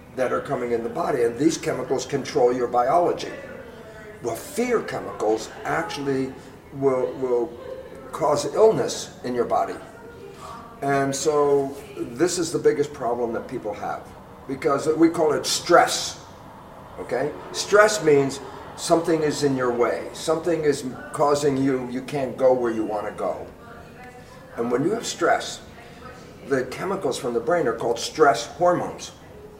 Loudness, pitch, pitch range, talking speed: -23 LUFS, 140 Hz, 130-170 Hz, 145 wpm